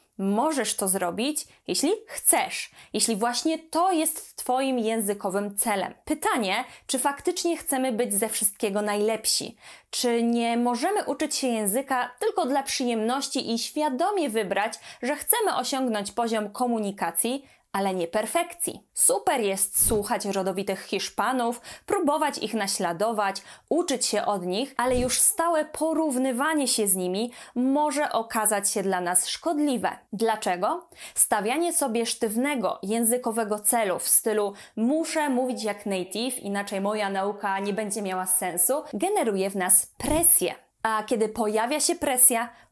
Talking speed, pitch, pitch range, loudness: 130 wpm, 235 Hz, 210-290 Hz, -24 LUFS